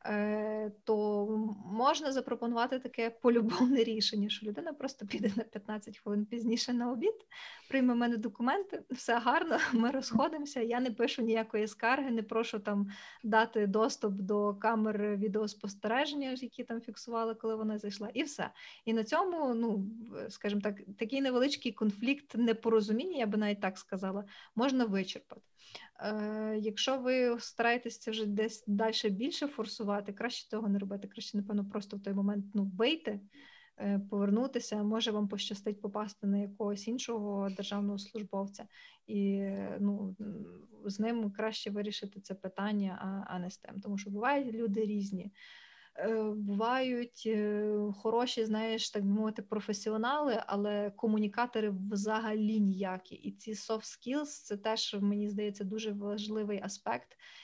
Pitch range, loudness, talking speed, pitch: 205-235 Hz, -34 LUFS, 135 wpm, 220 Hz